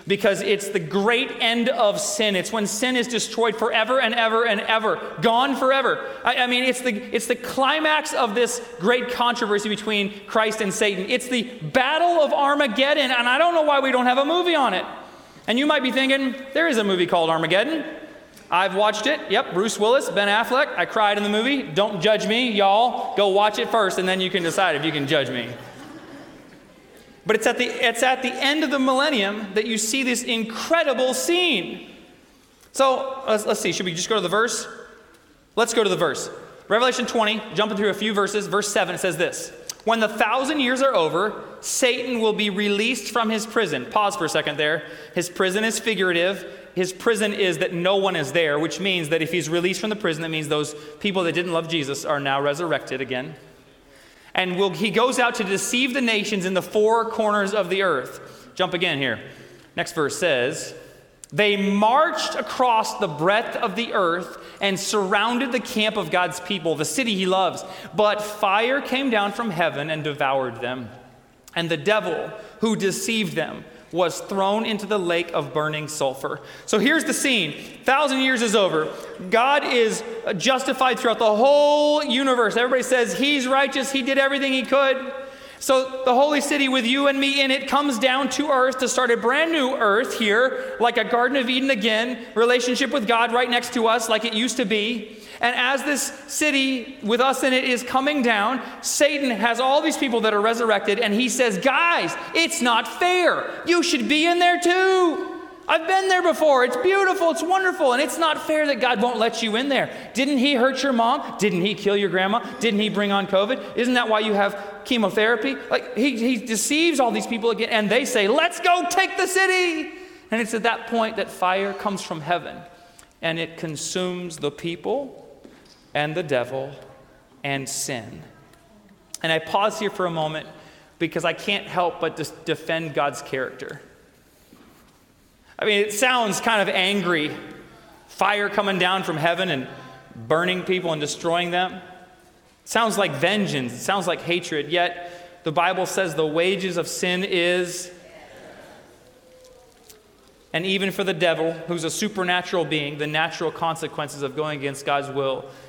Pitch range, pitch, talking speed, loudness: 180-260 Hz, 220 Hz, 190 wpm, -21 LUFS